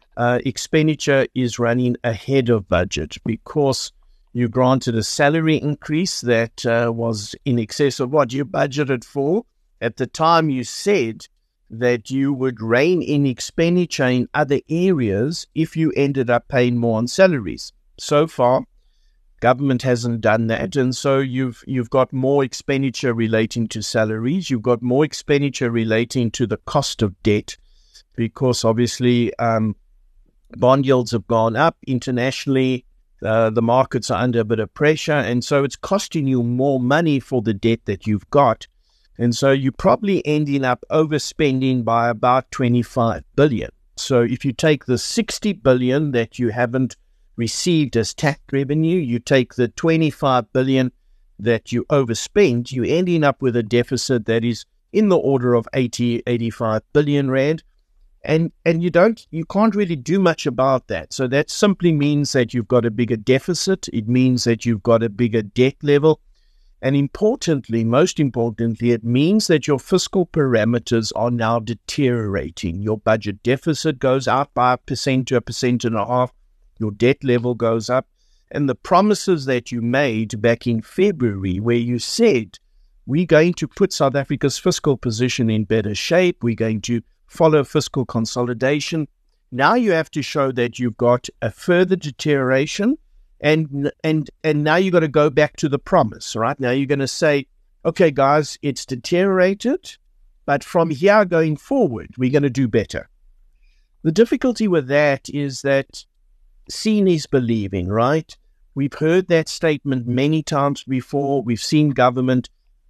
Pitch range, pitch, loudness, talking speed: 120-150 Hz, 130 Hz, -19 LUFS, 160 wpm